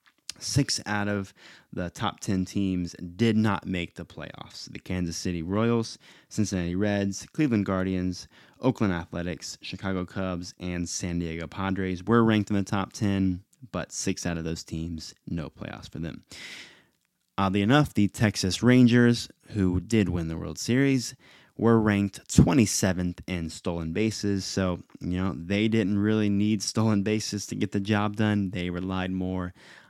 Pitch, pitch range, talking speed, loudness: 95 Hz, 90-110 Hz, 155 wpm, -27 LUFS